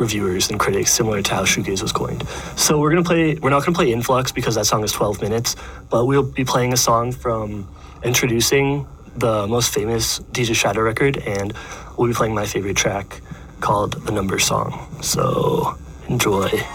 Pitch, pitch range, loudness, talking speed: 120 Hz, 110-135 Hz, -19 LUFS, 185 wpm